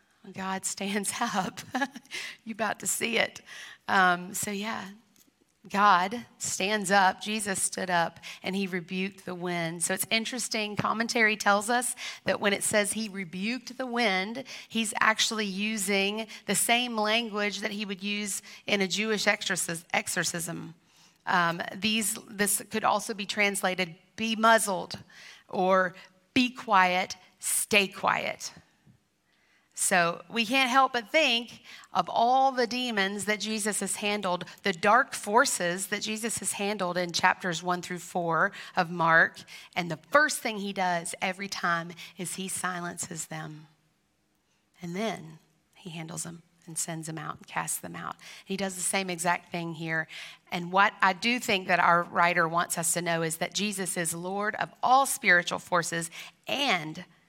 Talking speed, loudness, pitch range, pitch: 155 wpm, -27 LUFS, 180-220 Hz, 195 Hz